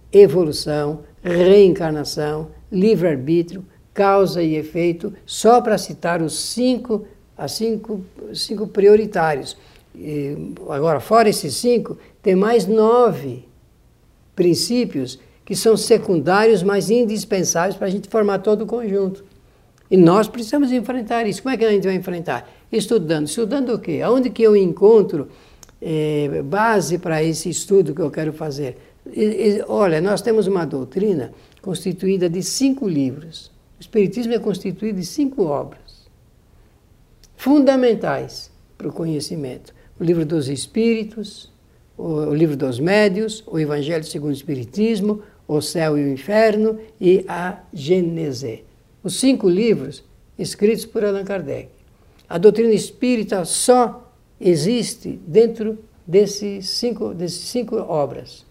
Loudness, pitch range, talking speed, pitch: -18 LUFS, 160-220 Hz, 130 wpm, 195 Hz